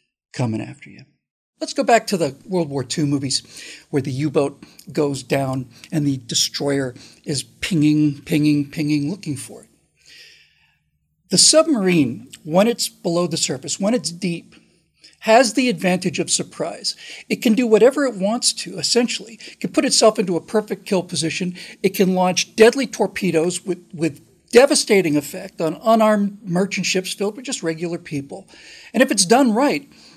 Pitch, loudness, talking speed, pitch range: 180 Hz, -19 LUFS, 165 wpm, 150-220 Hz